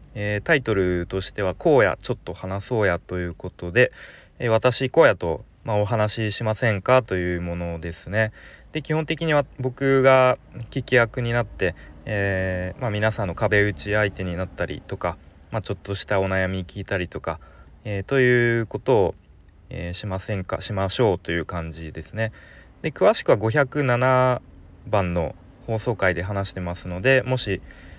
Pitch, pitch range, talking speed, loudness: 100 Hz, 90-120 Hz, 325 characters per minute, -23 LUFS